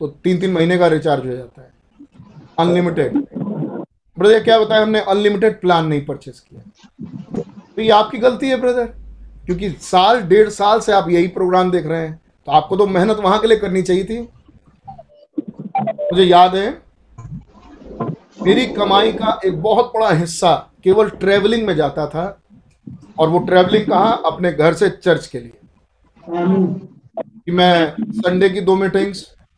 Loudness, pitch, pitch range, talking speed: -15 LUFS, 190 Hz, 170-215 Hz, 160 wpm